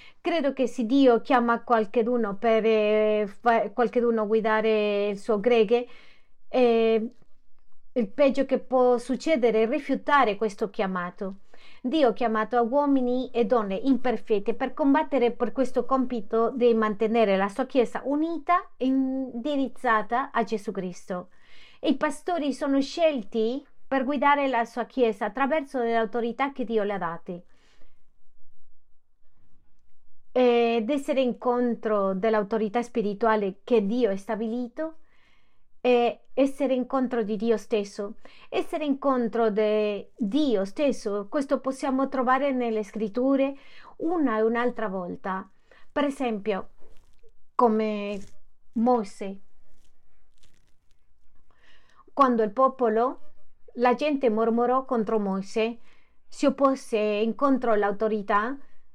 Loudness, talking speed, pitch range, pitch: -25 LUFS, 110 wpm, 220-270 Hz, 240 Hz